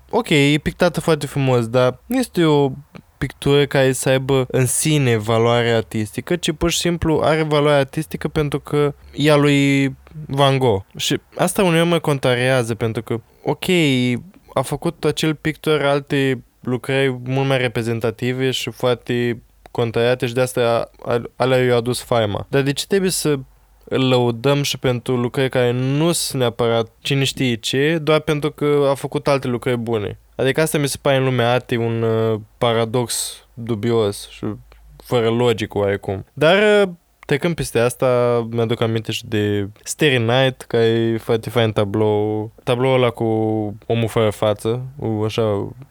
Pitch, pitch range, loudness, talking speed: 130 Hz, 115-145 Hz, -19 LUFS, 155 wpm